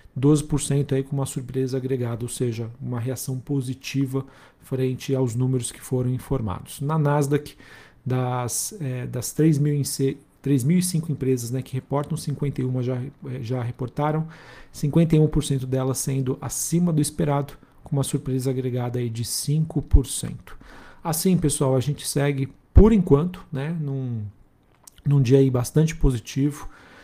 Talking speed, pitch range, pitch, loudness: 130 wpm, 130-145 Hz, 135 Hz, -24 LUFS